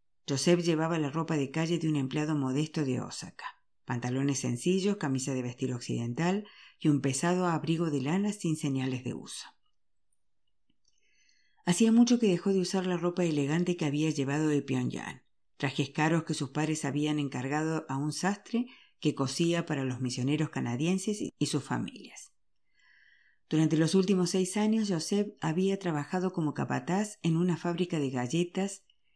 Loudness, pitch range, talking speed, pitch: -30 LUFS, 140-185 Hz, 155 wpm, 160 Hz